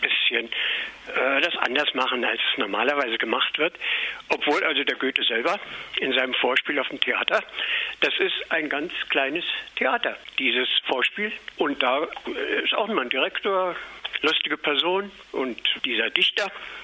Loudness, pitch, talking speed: -23 LUFS, 395 Hz, 145 wpm